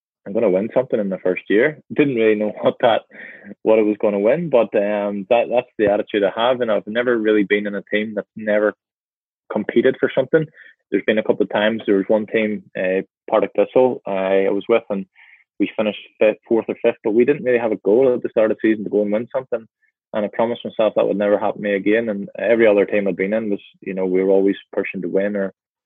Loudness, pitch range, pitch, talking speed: -19 LUFS, 100-115 Hz, 105 Hz, 255 wpm